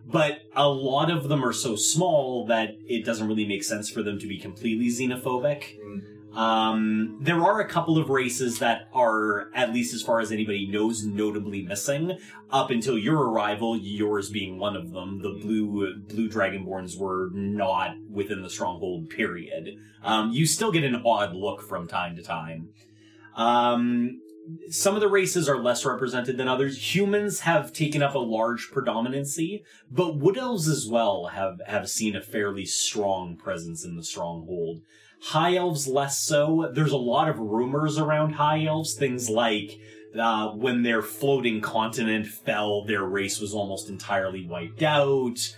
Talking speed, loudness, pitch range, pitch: 165 wpm, -26 LUFS, 105-140 Hz, 115 Hz